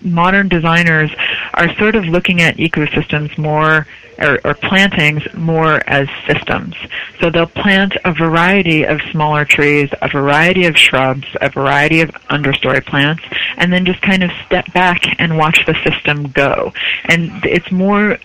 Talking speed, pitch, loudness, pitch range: 155 wpm, 165 Hz, -12 LUFS, 150-180 Hz